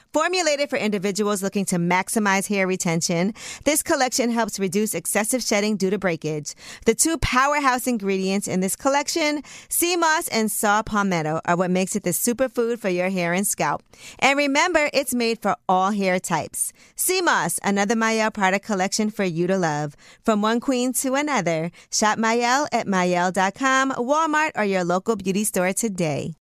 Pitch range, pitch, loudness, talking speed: 185-255 Hz, 210 Hz, -22 LUFS, 170 wpm